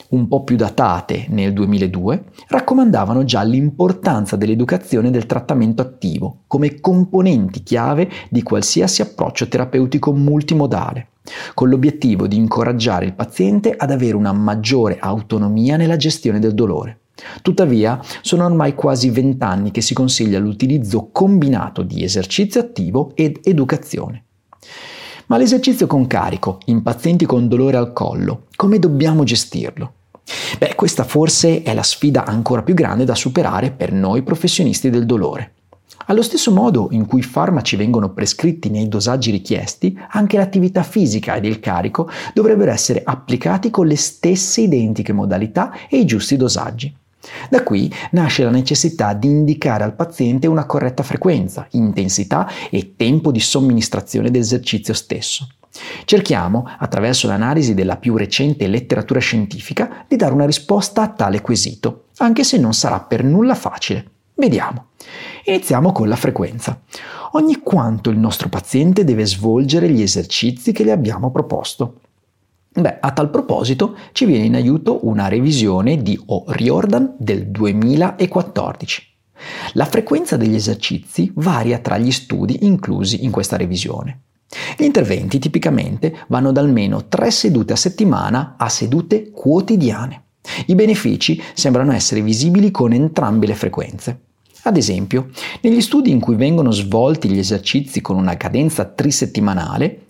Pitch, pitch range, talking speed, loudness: 130 Hz, 110-170 Hz, 140 wpm, -16 LUFS